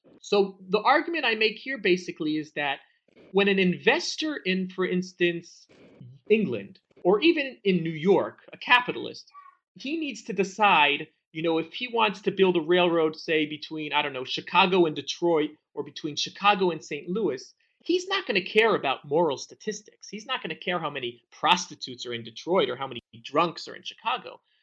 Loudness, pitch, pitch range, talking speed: -26 LUFS, 180 Hz, 155-220 Hz, 185 wpm